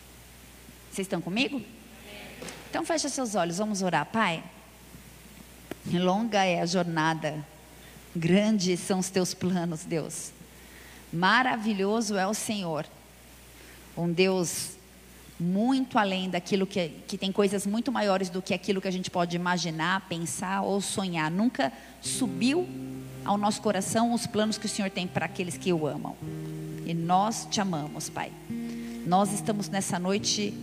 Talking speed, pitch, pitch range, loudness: 140 wpm, 190 Hz, 170-205 Hz, -28 LUFS